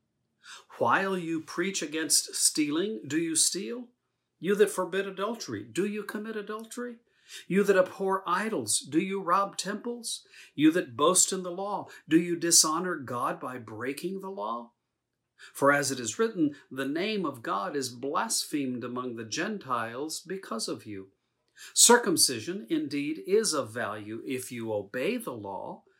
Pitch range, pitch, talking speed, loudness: 140-220 Hz, 185 Hz, 150 wpm, -28 LUFS